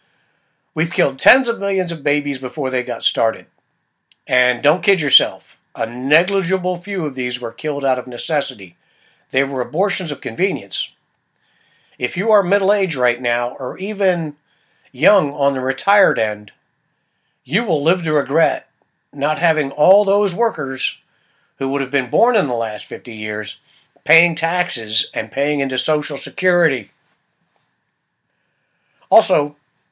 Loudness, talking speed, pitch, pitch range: -17 LUFS, 145 wpm, 145 Hz, 130-180 Hz